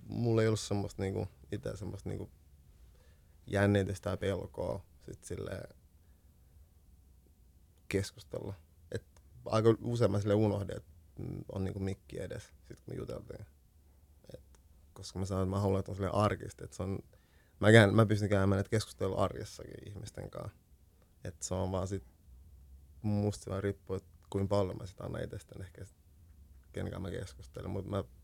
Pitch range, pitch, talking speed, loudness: 80-100 Hz, 95 Hz, 145 wpm, -34 LUFS